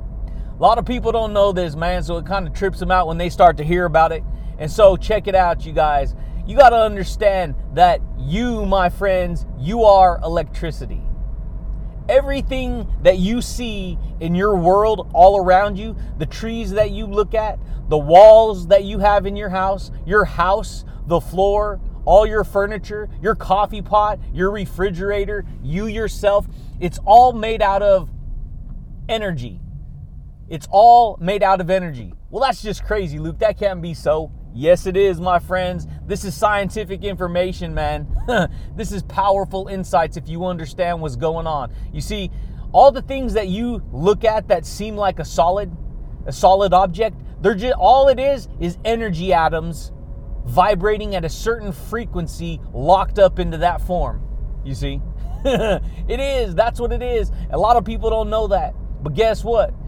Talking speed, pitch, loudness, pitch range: 170 wpm, 190 Hz, -17 LUFS, 170-215 Hz